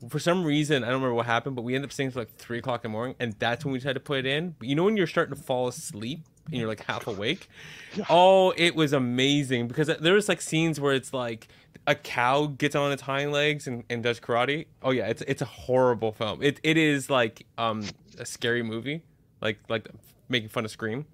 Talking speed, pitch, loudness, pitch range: 245 wpm, 135 Hz, -26 LUFS, 120-150 Hz